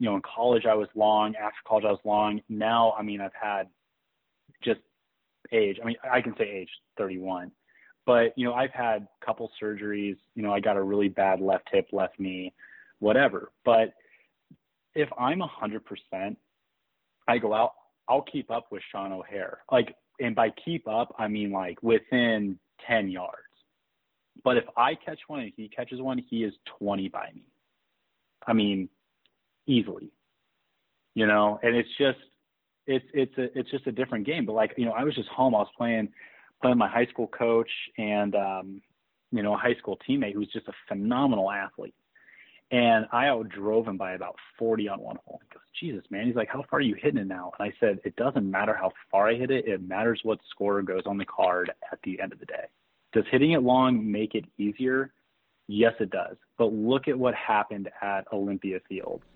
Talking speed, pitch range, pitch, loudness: 195 wpm, 100-120 Hz, 110 Hz, -28 LUFS